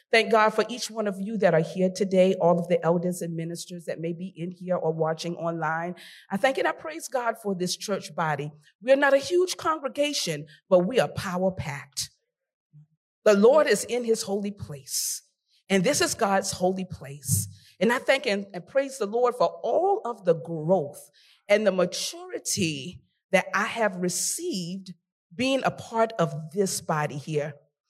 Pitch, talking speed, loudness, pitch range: 185 Hz, 185 wpm, -26 LUFS, 165-225 Hz